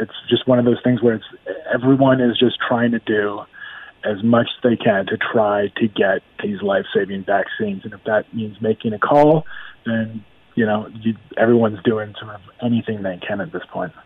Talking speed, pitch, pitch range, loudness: 205 wpm, 115 Hz, 105-120 Hz, -19 LUFS